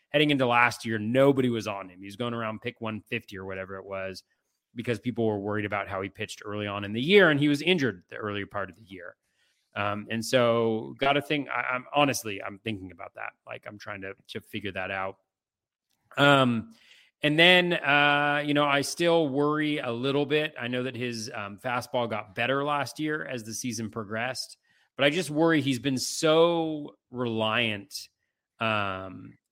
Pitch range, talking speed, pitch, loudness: 105-140 Hz, 200 wpm, 120 Hz, -26 LUFS